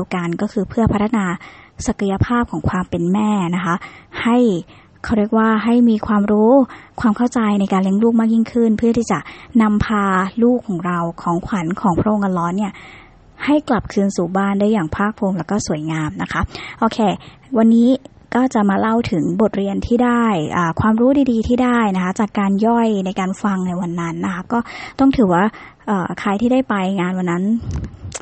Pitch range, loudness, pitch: 185-230 Hz, -17 LUFS, 210 Hz